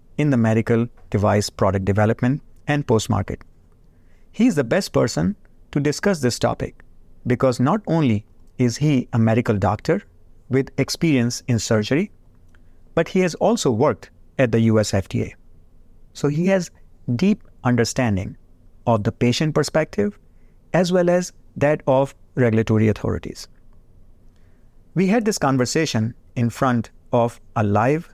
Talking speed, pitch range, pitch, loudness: 135 wpm, 105-145 Hz, 120 Hz, -21 LUFS